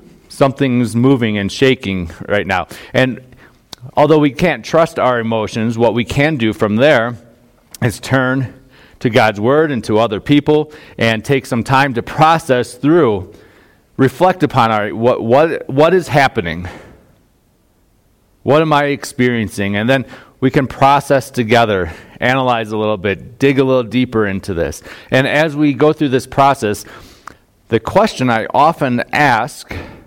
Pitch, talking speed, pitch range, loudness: 125 Hz, 150 wpm, 110-140 Hz, -14 LUFS